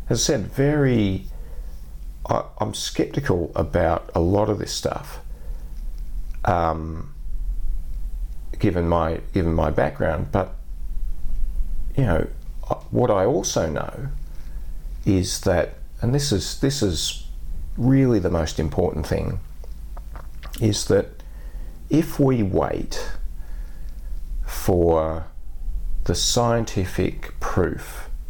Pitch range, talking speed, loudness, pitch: 75-100 Hz, 100 wpm, -23 LUFS, 80 Hz